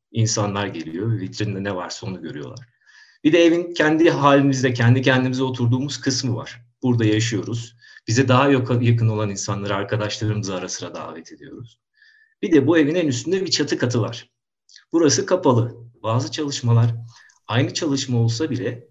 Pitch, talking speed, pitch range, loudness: 120 Hz, 150 wpm, 110-140 Hz, -20 LUFS